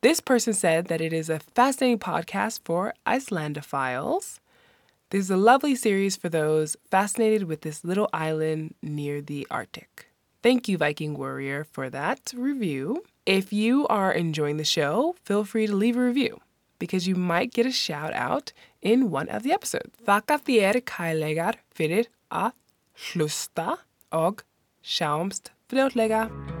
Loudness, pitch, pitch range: -25 LUFS, 195 Hz, 155-235 Hz